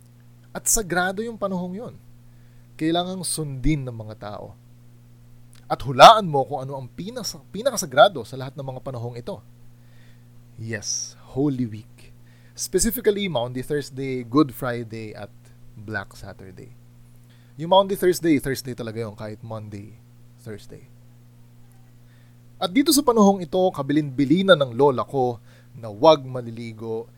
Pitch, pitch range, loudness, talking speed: 120 Hz, 120-155 Hz, -21 LUFS, 125 wpm